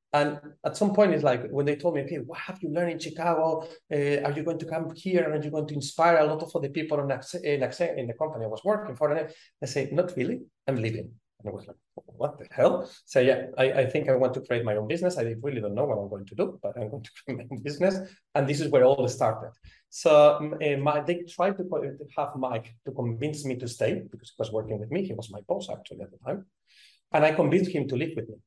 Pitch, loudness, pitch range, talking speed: 150 Hz, -27 LUFS, 130-165 Hz, 275 wpm